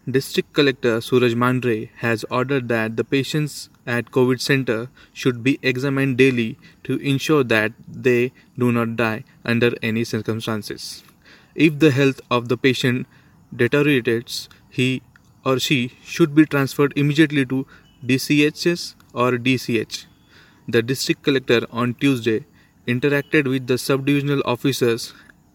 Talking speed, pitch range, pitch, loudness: 125 wpm, 120-140 Hz, 130 Hz, -20 LUFS